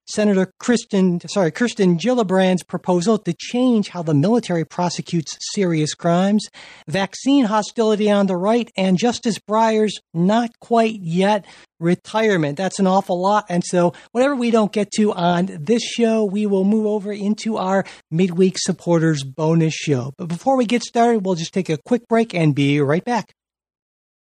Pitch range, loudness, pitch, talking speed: 175-220 Hz, -19 LUFS, 195 Hz, 160 wpm